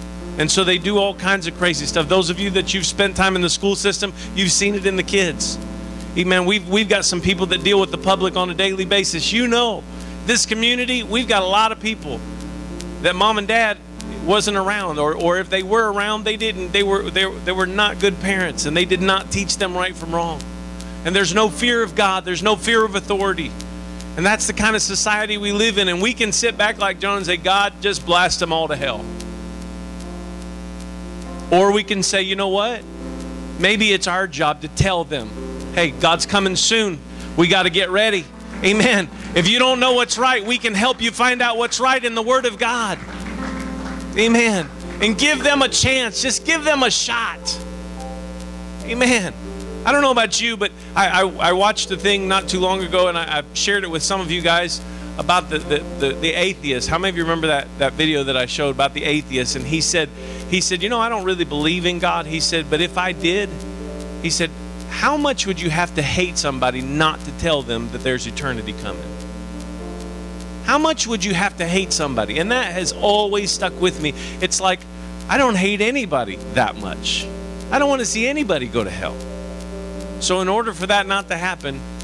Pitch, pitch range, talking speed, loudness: 185 Hz, 155-205 Hz, 215 wpm, -18 LUFS